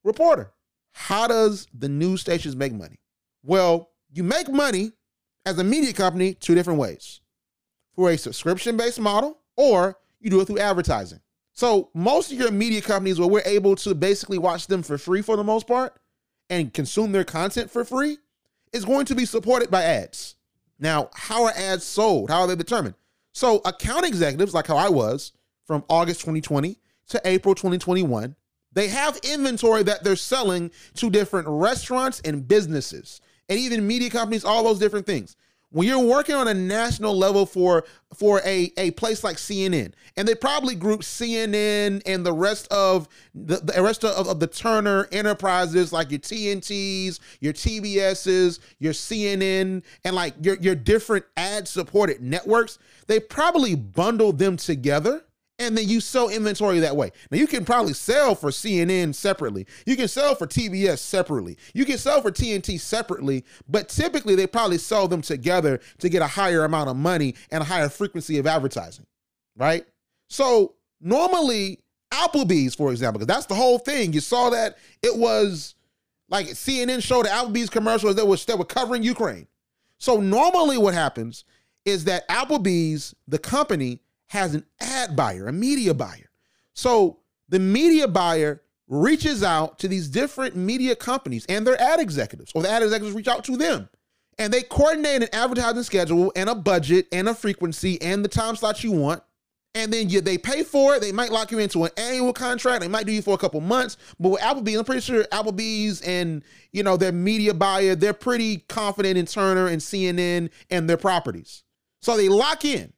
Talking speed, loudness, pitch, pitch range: 180 wpm, -22 LUFS, 200 Hz, 175-230 Hz